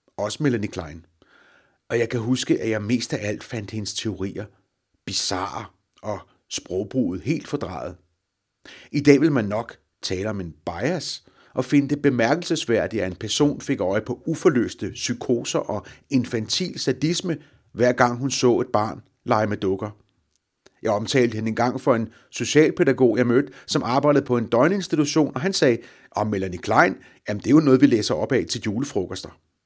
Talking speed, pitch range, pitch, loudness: 170 wpm, 100-140 Hz, 115 Hz, -23 LUFS